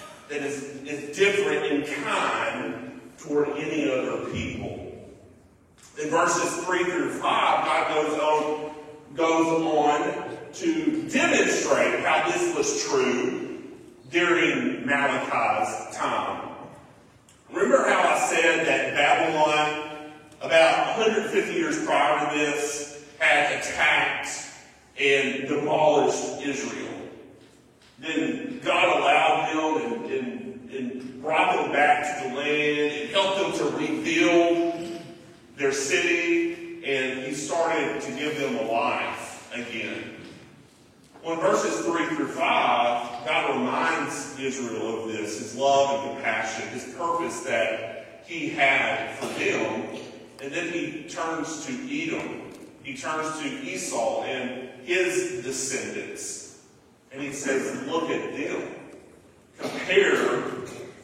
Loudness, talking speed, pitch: -25 LUFS, 110 wpm, 155 Hz